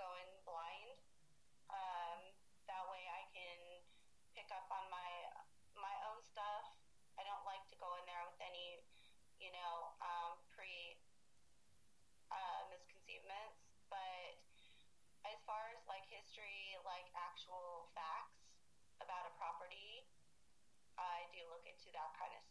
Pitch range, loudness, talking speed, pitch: 170-195 Hz, -52 LUFS, 130 wpm, 180 Hz